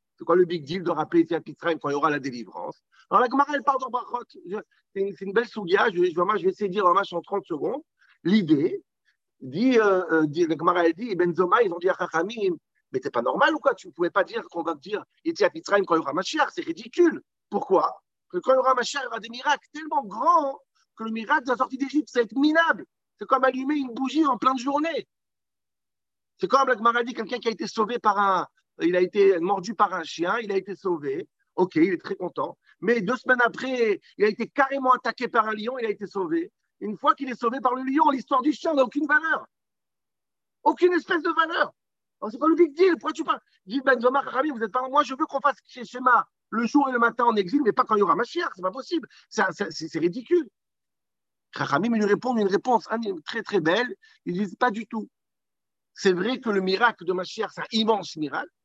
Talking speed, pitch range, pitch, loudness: 245 wpm, 195-285 Hz, 235 Hz, -24 LUFS